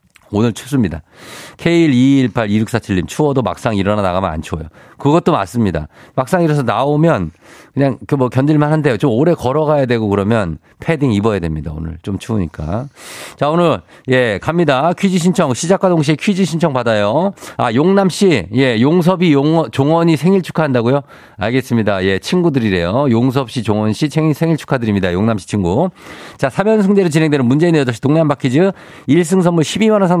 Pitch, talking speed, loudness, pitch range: 135 Hz, 355 characters per minute, -14 LUFS, 110-165 Hz